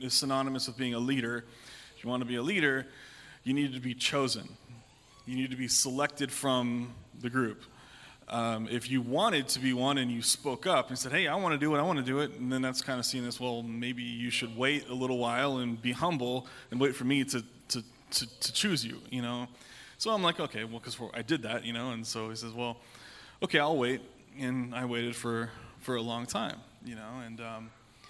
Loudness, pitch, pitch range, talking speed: -32 LUFS, 125 Hz, 120-130 Hz, 235 wpm